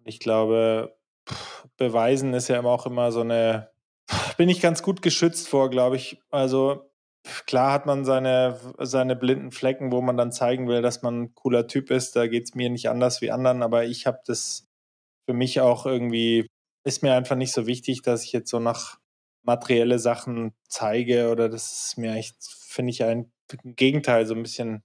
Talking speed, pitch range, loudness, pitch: 190 wpm, 115-130 Hz, -24 LUFS, 125 Hz